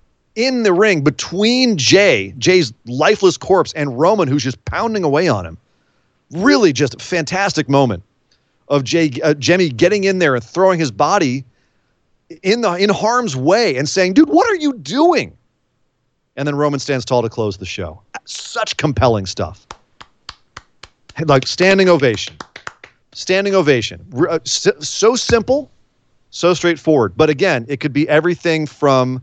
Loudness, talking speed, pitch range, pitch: -15 LUFS, 150 wpm, 130-195 Hz, 155 Hz